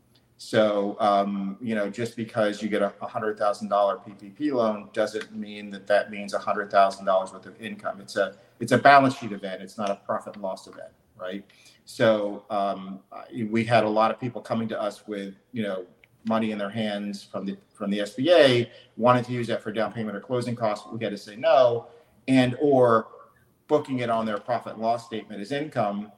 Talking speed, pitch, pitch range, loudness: 195 wpm, 110 Hz, 100-120 Hz, -25 LUFS